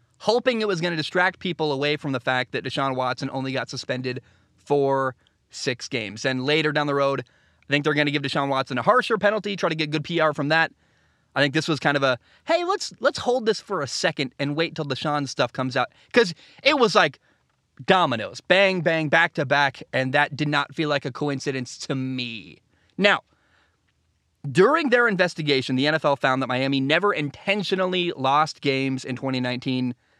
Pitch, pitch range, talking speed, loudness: 145 Hz, 130-165 Hz, 195 wpm, -23 LUFS